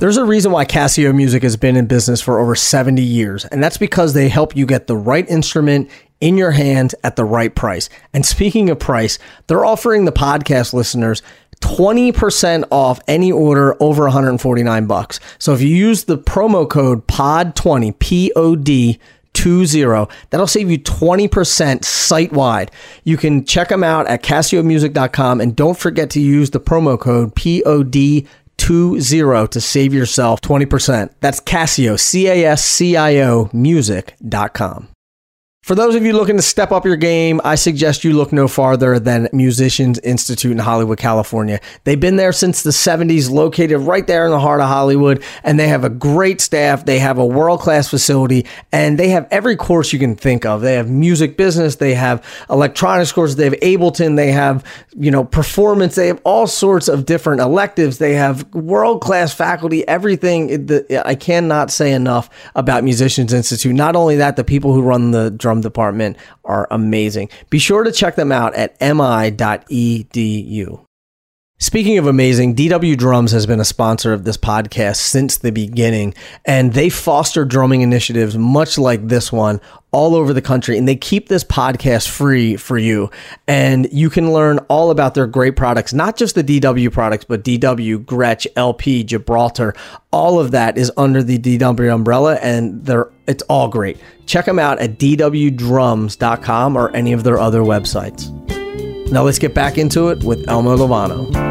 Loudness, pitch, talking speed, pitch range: -13 LUFS, 135 Hz, 170 wpm, 120-160 Hz